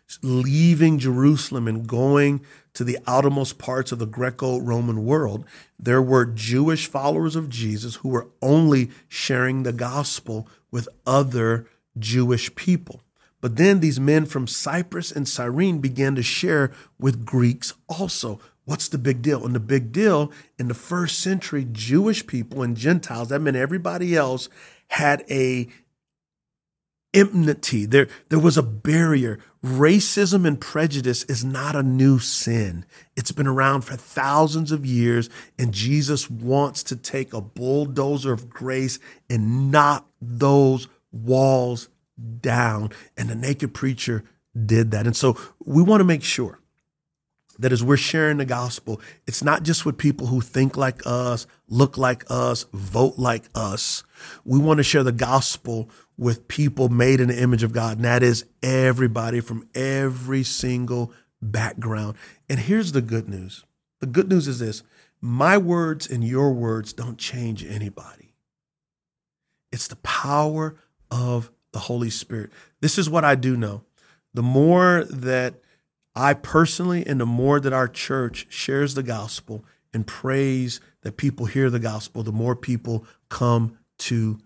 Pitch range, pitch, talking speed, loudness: 120-145 Hz, 130 Hz, 150 wpm, -22 LUFS